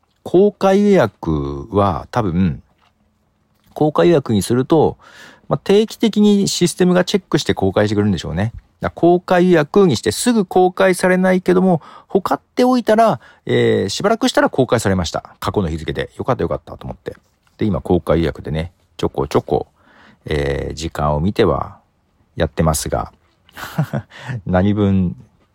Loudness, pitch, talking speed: -17 LUFS, 110 Hz, 315 characters per minute